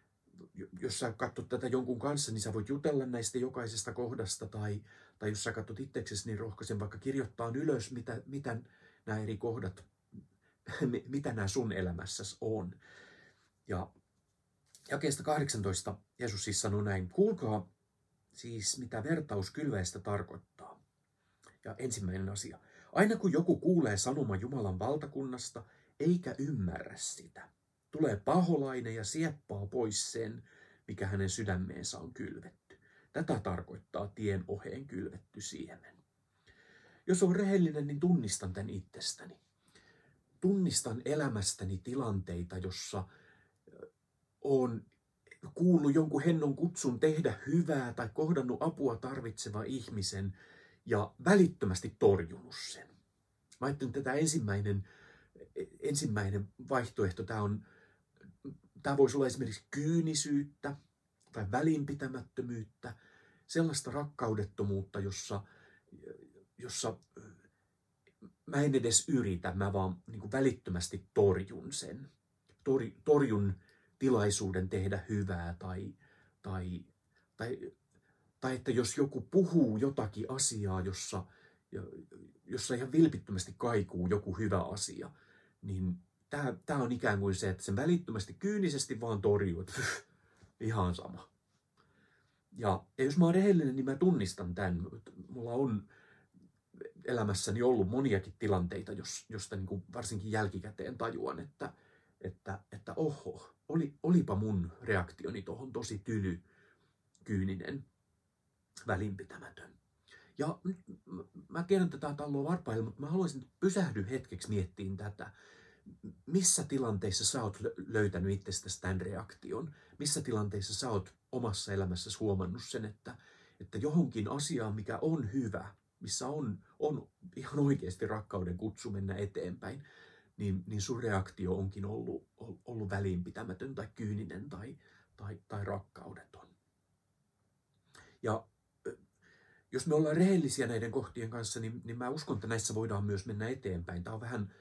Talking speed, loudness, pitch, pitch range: 115 wpm, -35 LUFS, 110 Hz, 100-135 Hz